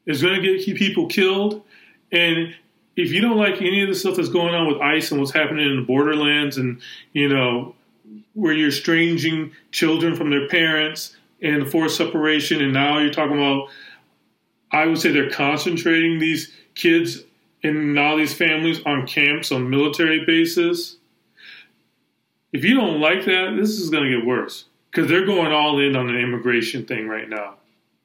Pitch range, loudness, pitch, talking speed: 140-175 Hz, -19 LUFS, 155 Hz, 175 wpm